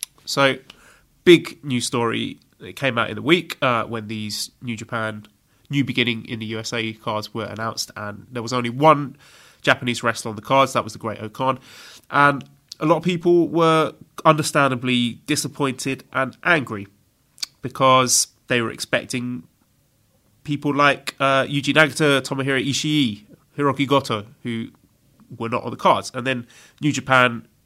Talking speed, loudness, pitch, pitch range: 155 wpm, -20 LUFS, 130 Hz, 115-140 Hz